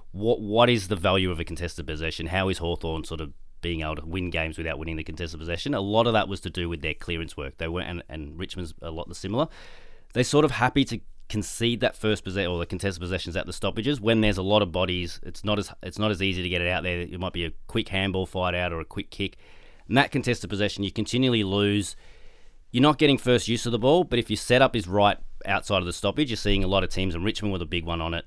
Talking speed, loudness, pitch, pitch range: 275 wpm, -26 LUFS, 95 Hz, 85-110 Hz